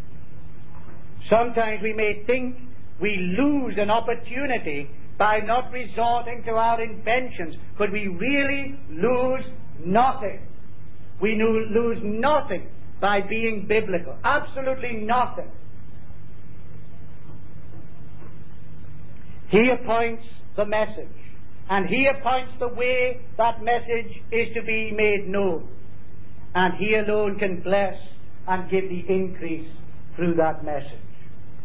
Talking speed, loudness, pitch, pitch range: 105 wpm, -24 LUFS, 215 Hz, 175-235 Hz